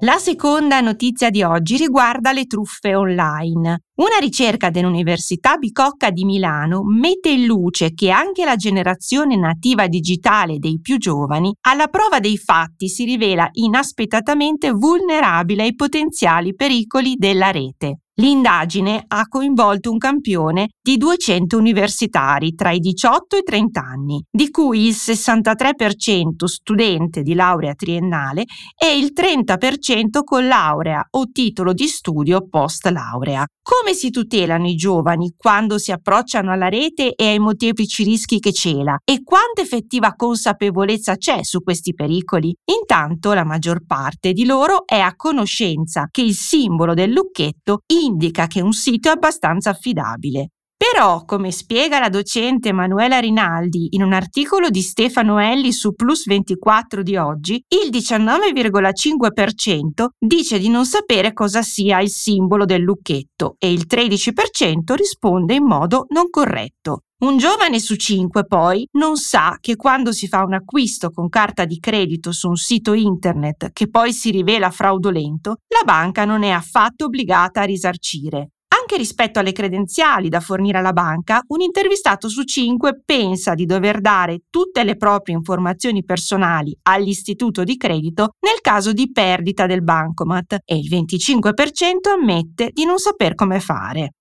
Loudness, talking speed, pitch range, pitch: -16 LUFS, 145 wpm, 180-255 Hz, 210 Hz